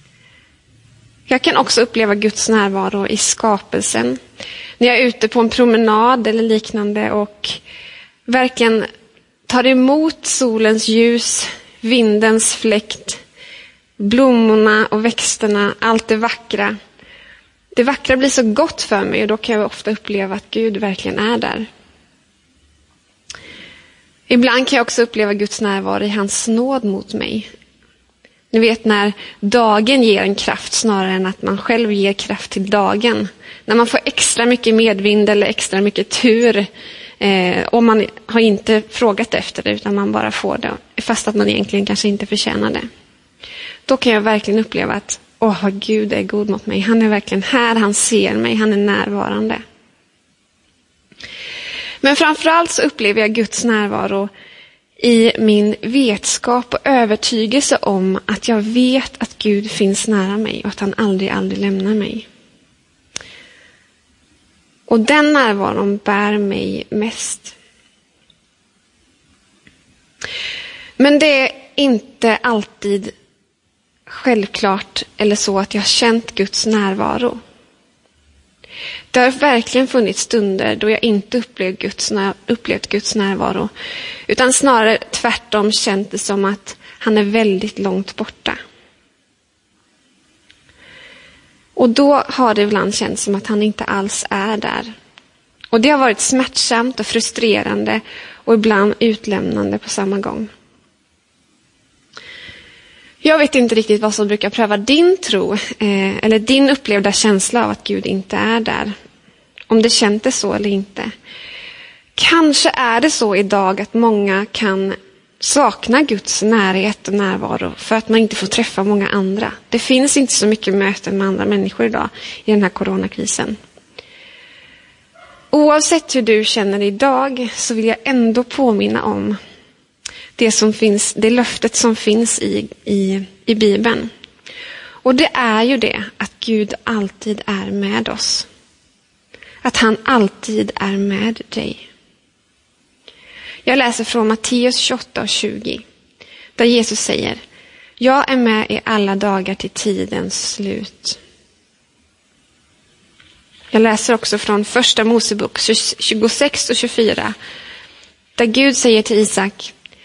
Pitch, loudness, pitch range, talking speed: 220 Hz, -15 LUFS, 205-245 Hz, 135 wpm